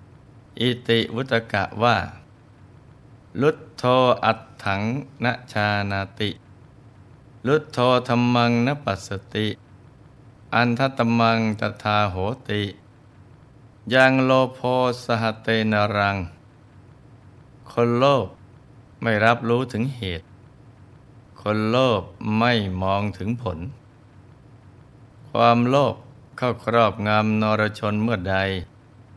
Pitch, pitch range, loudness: 115 Hz, 105-125 Hz, -22 LUFS